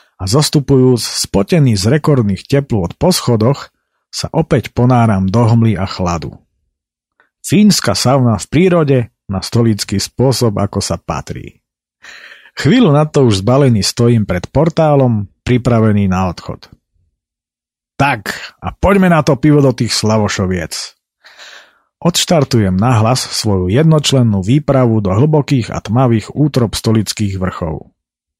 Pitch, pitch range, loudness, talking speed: 120 Hz, 100-140 Hz, -13 LUFS, 120 wpm